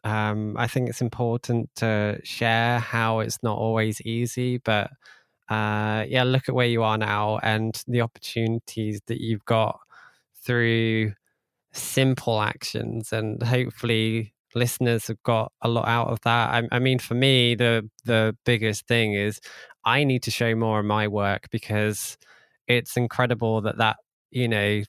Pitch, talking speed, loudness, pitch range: 115 Hz, 155 wpm, -24 LUFS, 110-120 Hz